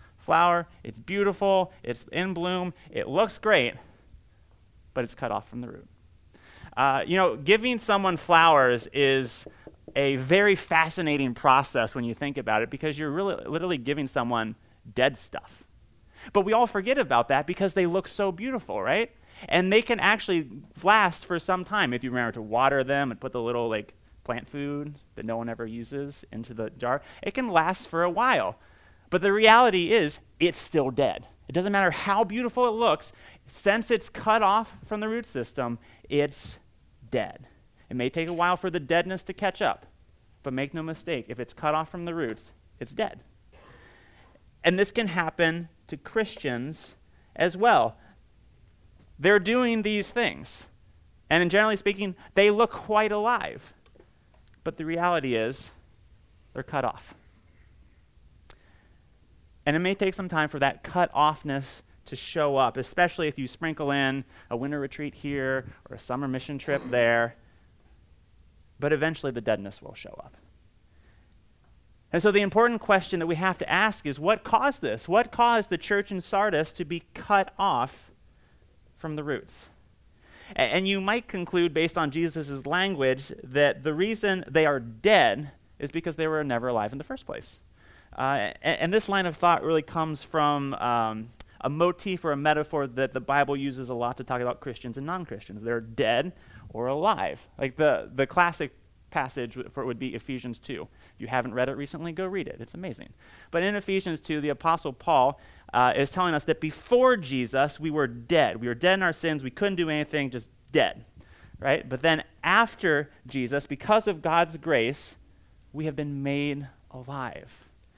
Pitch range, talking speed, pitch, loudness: 120-185 Hz, 175 wpm, 150 Hz, -26 LUFS